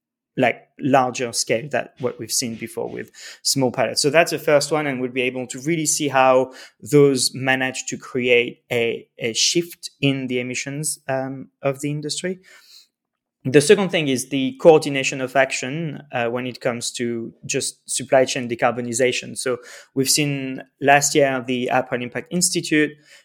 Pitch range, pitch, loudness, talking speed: 125-145 Hz, 135 Hz, -20 LUFS, 165 wpm